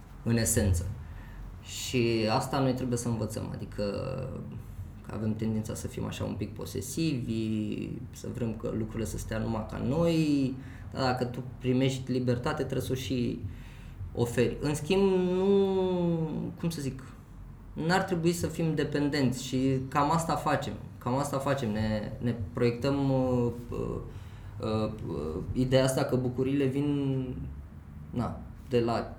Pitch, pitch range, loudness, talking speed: 120 Hz, 110-135 Hz, -30 LUFS, 140 wpm